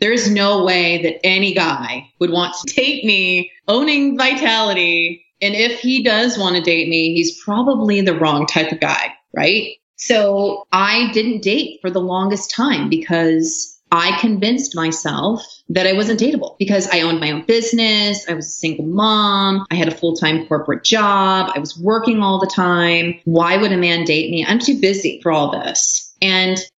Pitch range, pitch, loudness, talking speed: 170-215 Hz, 190 Hz, -15 LUFS, 185 wpm